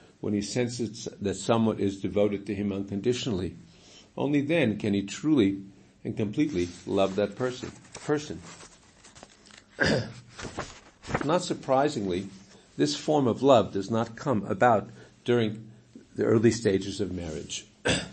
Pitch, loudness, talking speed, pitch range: 105 Hz, -28 LUFS, 120 wpm, 100-120 Hz